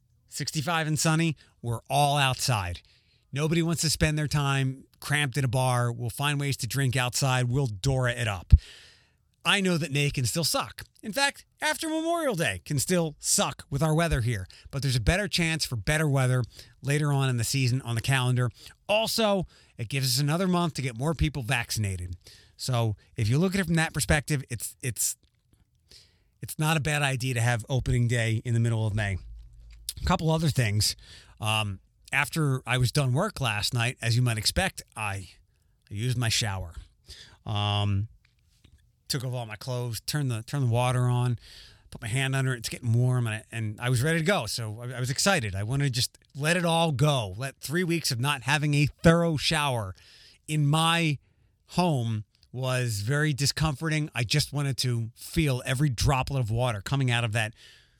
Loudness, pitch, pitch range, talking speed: -27 LUFS, 130 Hz, 115-150 Hz, 195 wpm